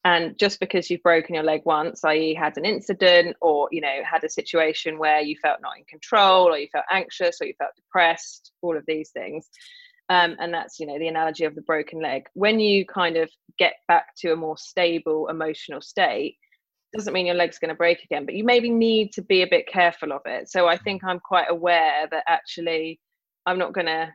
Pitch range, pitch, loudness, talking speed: 160-200 Hz, 170 Hz, -22 LUFS, 225 wpm